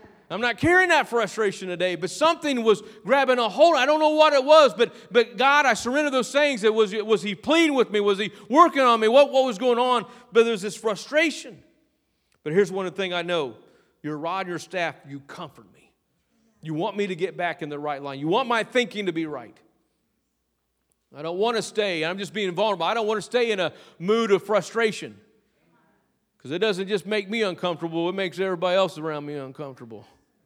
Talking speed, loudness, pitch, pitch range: 215 wpm, -22 LUFS, 210 Hz, 175-240 Hz